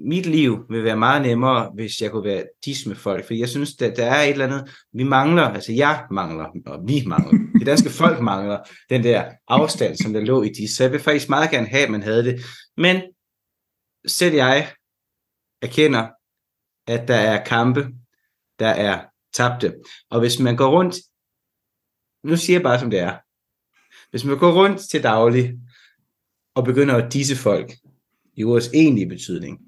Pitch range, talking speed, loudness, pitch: 115-145 Hz, 185 wpm, -19 LUFS, 125 Hz